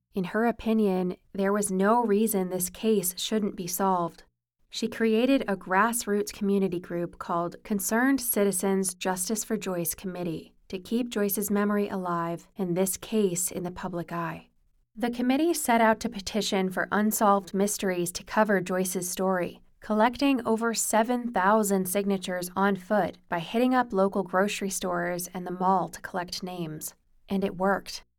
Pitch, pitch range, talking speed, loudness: 195 Hz, 180-215 Hz, 150 wpm, -27 LUFS